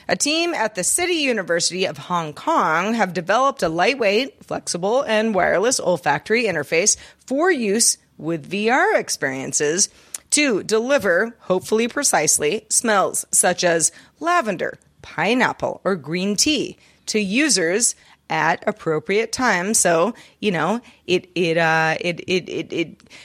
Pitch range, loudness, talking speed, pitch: 175-245 Hz, -19 LUFS, 130 wpm, 210 Hz